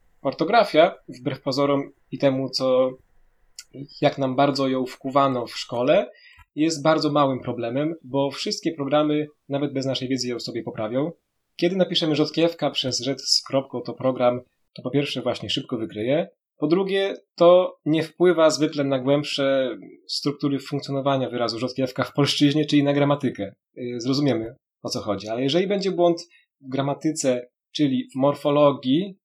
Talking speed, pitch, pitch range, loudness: 150 wpm, 140 Hz, 130-150 Hz, -23 LUFS